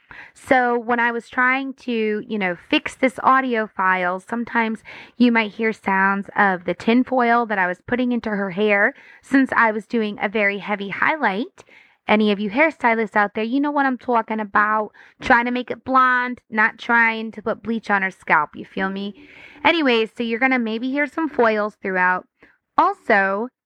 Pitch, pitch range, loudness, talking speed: 225 Hz, 210-250 Hz, -20 LUFS, 190 wpm